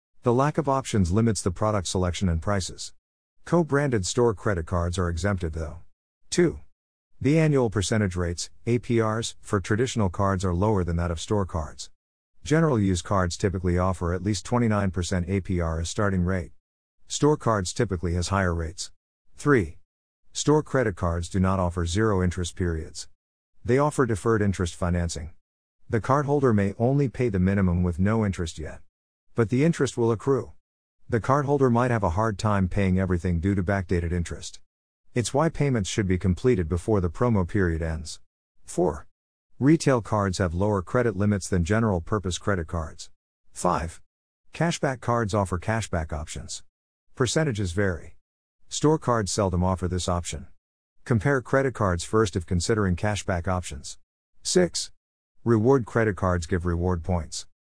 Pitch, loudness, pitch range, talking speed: 95 Hz, -25 LUFS, 85-115 Hz, 155 wpm